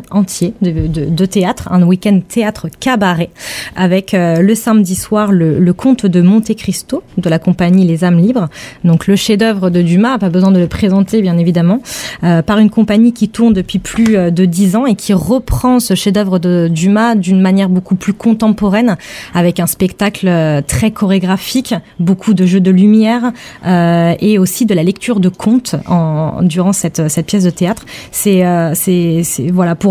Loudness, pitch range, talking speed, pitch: -11 LUFS, 175-210 Hz, 185 wpm, 190 Hz